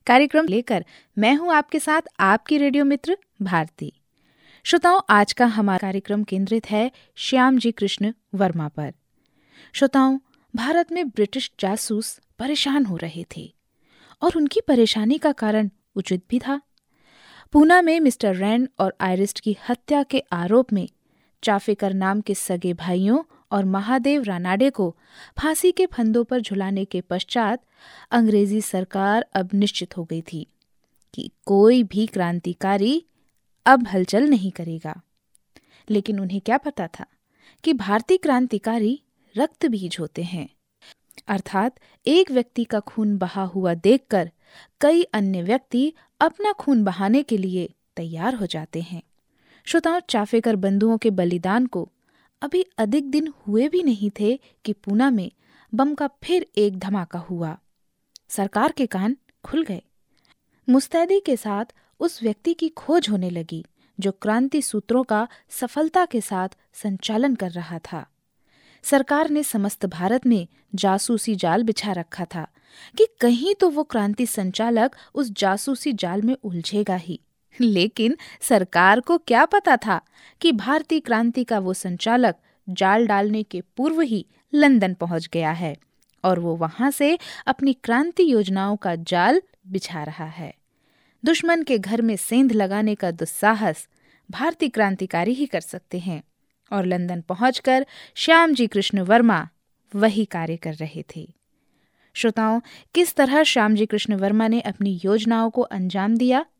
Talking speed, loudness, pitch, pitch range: 140 wpm, -21 LUFS, 220 Hz, 190-270 Hz